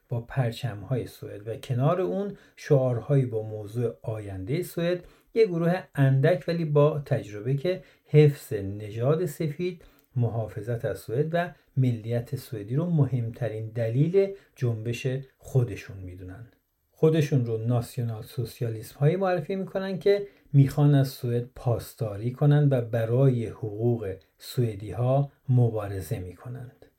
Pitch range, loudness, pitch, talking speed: 115-150 Hz, -27 LUFS, 130 Hz, 120 wpm